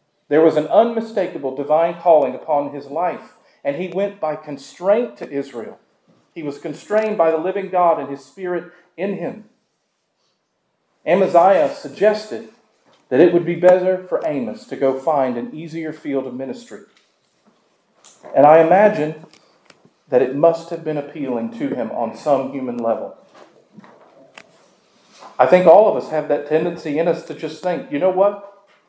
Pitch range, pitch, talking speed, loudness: 140-180 Hz, 160 Hz, 160 wpm, -18 LUFS